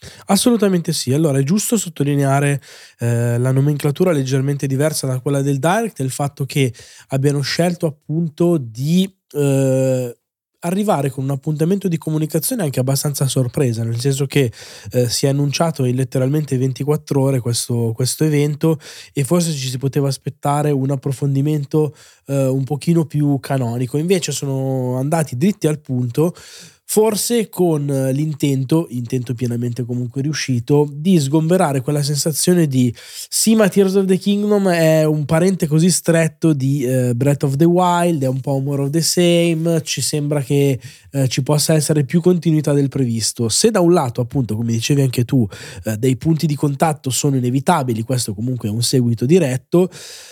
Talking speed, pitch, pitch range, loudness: 160 wpm, 145 Hz, 130-165 Hz, -17 LUFS